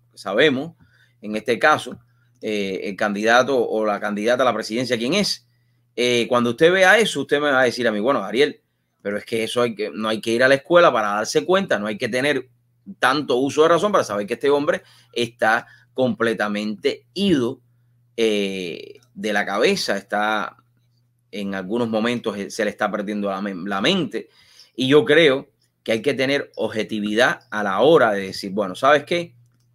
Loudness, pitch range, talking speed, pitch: -20 LUFS, 105-135 Hz, 185 wpm, 120 Hz